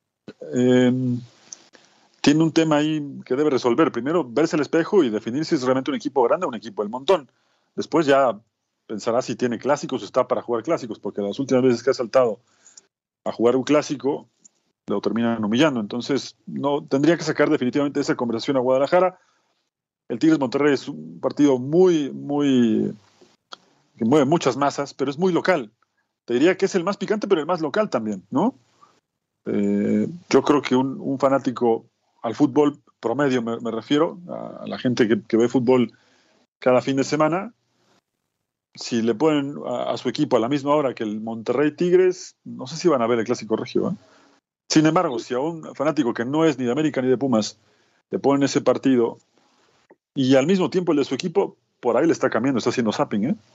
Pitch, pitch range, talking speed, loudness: 135 Hz, 120-155 Hz, 195 wpm, -21 LUFS